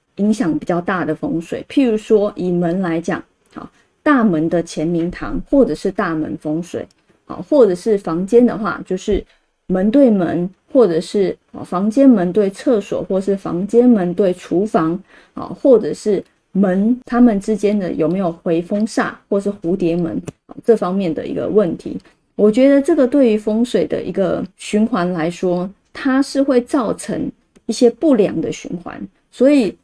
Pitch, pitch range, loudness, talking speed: 205 Hz, 175-240 Hz, -17 LUFS, 235 characters per minute